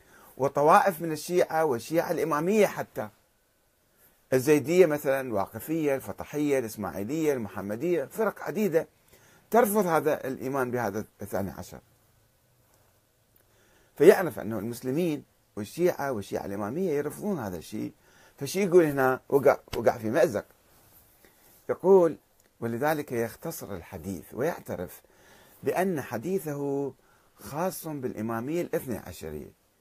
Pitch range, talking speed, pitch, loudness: 105-165 Hz, 95 wpm, 135 Hz, -27 LUFS